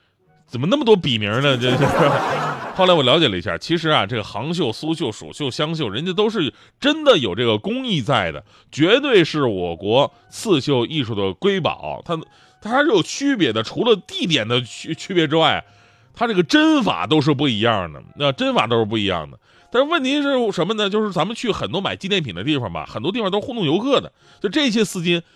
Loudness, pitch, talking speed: -19 LUFS, 160 Hz, 310 characters per minute